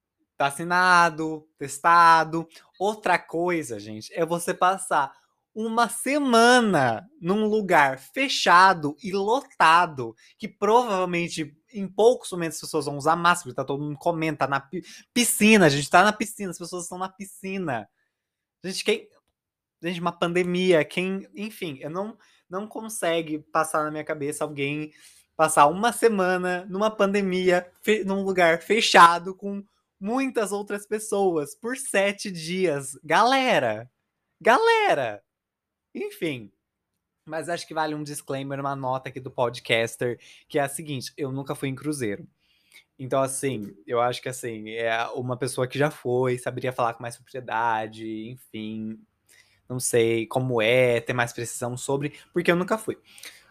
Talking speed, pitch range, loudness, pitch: 140 wpm, 135-195 Hz, -23 LUFS, 165 Hz